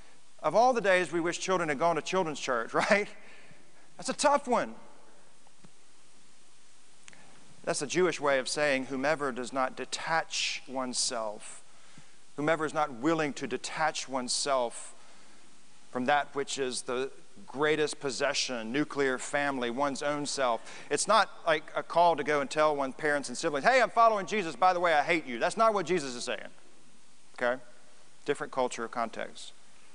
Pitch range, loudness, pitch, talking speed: 130-170 Hz, -29 LUFS, 150 Hz, 160 wpm